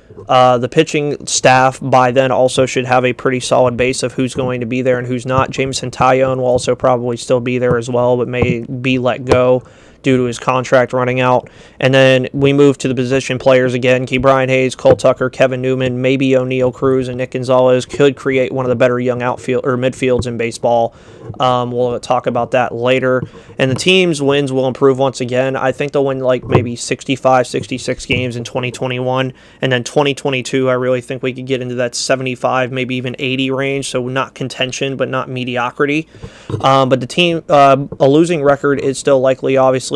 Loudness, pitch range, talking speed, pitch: -14 LUFS, 125-135 Hz, 205 wpm, 130 Hz